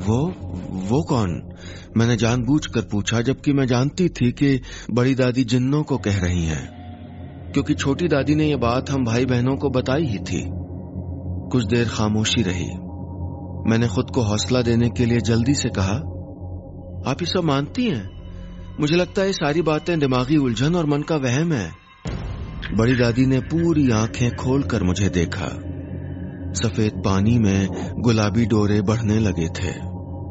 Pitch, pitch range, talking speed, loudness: 115 Hz, 90-135 Hz, 155 wpm, -21 LUFS